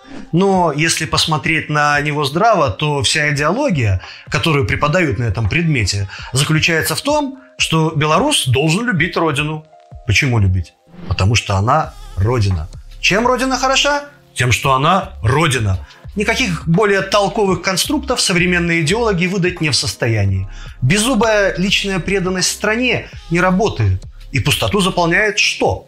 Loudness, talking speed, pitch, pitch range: -15 LUFS, 130 wpm, 160 Hz, 120-190 Hz